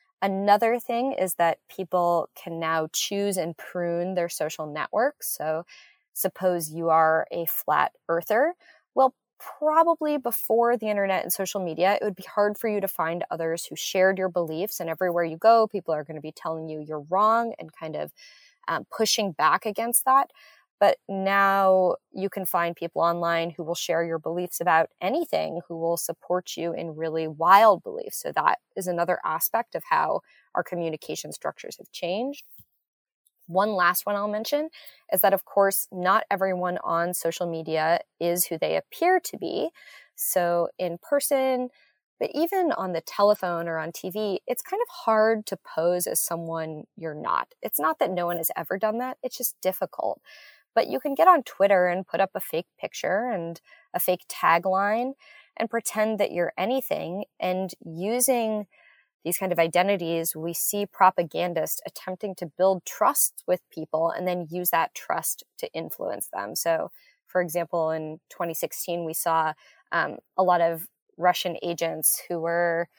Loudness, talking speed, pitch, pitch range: -25 LUFS, 170 wpm, 185 Hz, 170-225 Hz